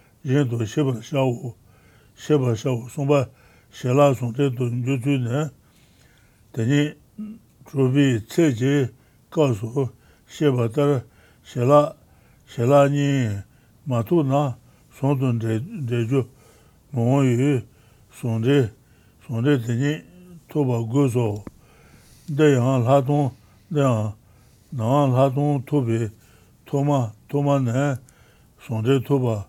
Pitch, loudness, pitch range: 130 Hz, -22 LUFS, 115-140 Hz